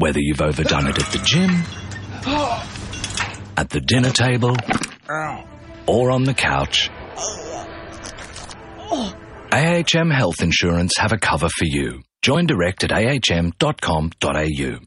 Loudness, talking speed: -19 LUFS, 110 wpm